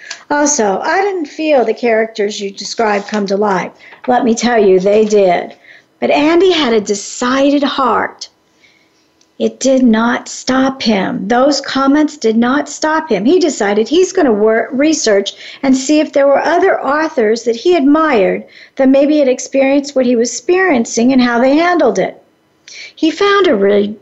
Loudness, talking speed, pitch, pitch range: -12 LUFS, 170 wpm, 260 Hz, 220-300 Hz